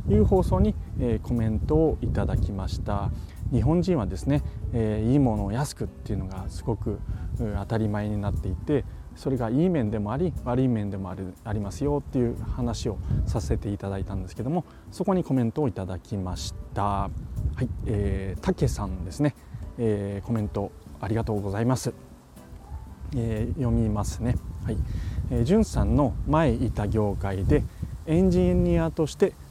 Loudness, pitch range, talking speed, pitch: -27 LUFS, 95-125 Hz, 340 characters per minute, 105 Hz